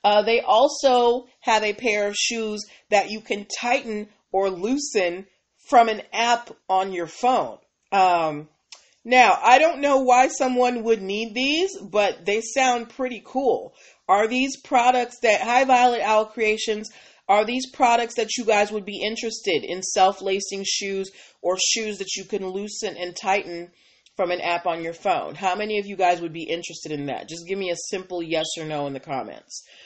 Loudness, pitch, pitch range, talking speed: -22 LUFS, 210 Hz, 190-240 Hz, 180 wpm